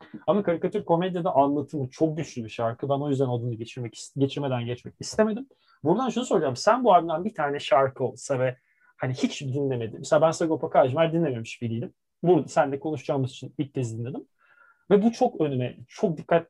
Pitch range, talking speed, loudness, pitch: 125-175 Hz, 180 wpm, -26 LUFS, 145 Hz